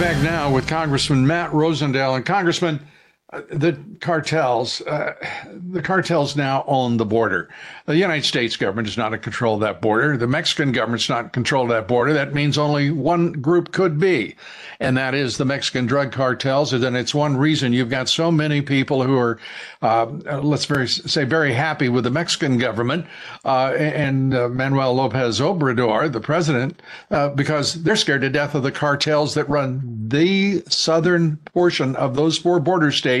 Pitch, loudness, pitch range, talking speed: 145 Hz, -19 LUFS, 130-160 Hz, 180 wpm